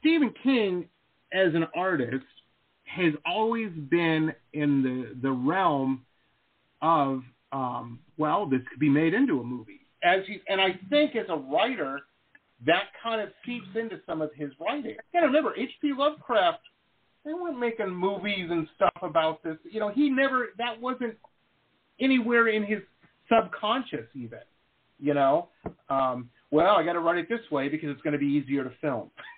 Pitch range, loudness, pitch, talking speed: 145-235 Hz, -27 LUFS, 175 Hz, 170 wpm